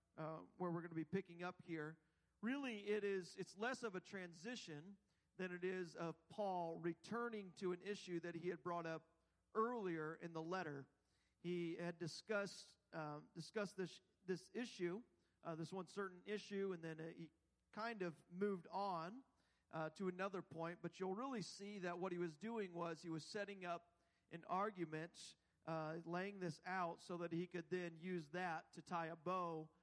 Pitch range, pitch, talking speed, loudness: 165-195 Hz, 175 Hz, 185 wpm, -49 LUFS